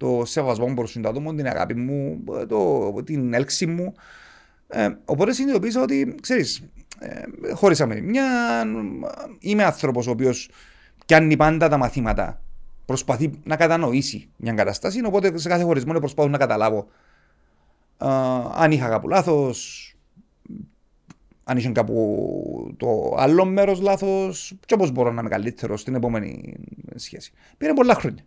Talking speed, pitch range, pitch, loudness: 135 wpm, 120-190 Hz, 140 Hz, -22 LUFS